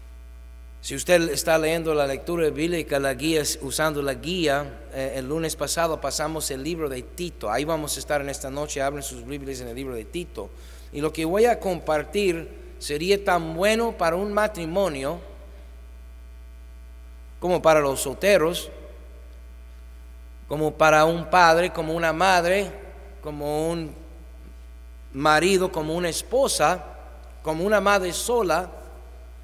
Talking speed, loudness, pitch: 140 wpm, -23 LUFS, 150 Hz